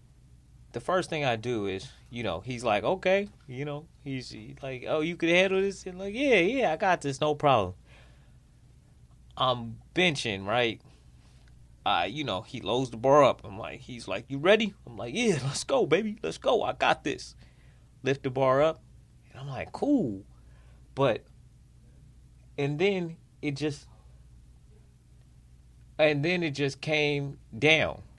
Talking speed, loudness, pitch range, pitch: 165 wpm, -28 LUFS, 115-160 Hz, 135 Hz